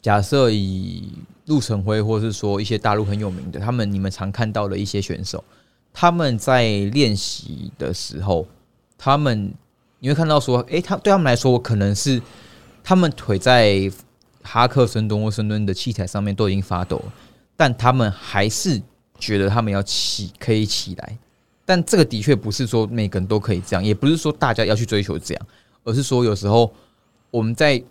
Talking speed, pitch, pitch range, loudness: 275 characters per minute, 110 Hz, 100-125 Hz, -20 LUFS